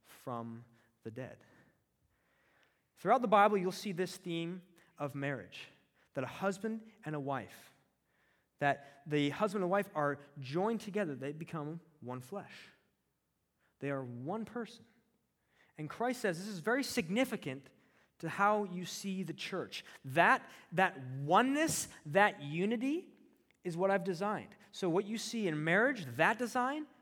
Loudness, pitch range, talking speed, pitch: -35 LUFS, 145-210 Hz, 140 wpm, 180 Hz